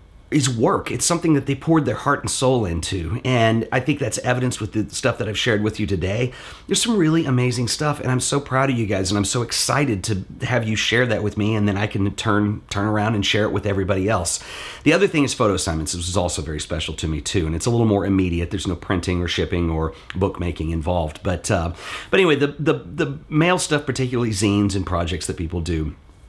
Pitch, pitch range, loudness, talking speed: 105 Hz, 95-125 Hz, -21 LUFS, 240 wpm